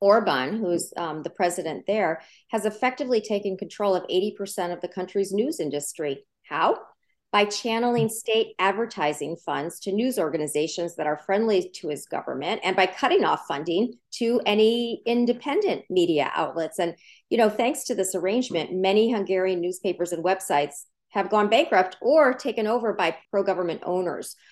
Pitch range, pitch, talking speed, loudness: 175-225 Hz, 195 Hz, 155 wpm, -25 LUFS